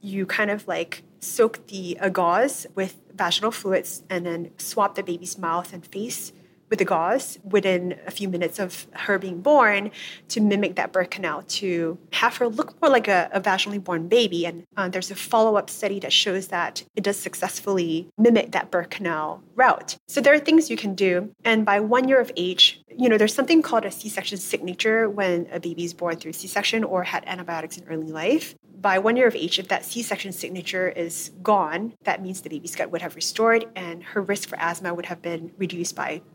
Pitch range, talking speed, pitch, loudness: 175-210 Hz, 215 wpm, 190 Hz, -23 LUFS